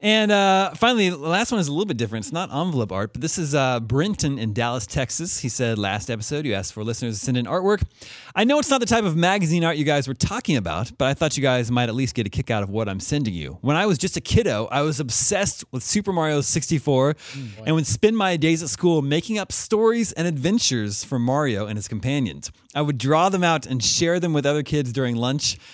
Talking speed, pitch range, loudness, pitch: 255 wpm, 120-170 Hz, -22 LUFS, 145 Hz